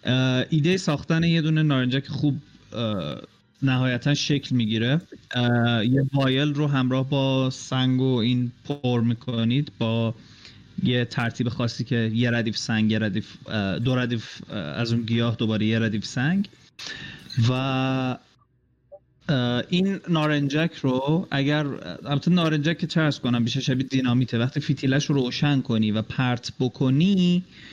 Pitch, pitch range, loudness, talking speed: 130 Hz, 120-145 Hz, -24 LUFS, 130 wpm